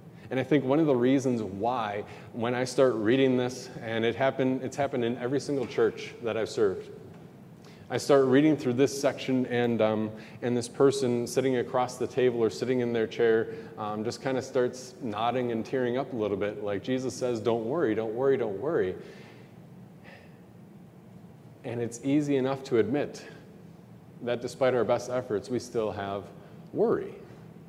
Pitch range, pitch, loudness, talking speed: 115-135 Hz, 125 Hz, -28 LUFS, 175 wpm